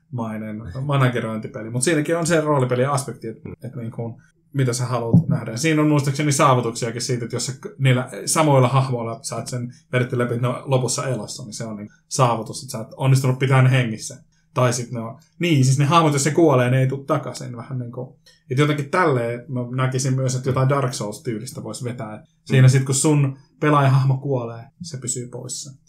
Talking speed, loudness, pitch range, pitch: 195 wpm, -20 LUFS, 120-145 Hz, 130 Hz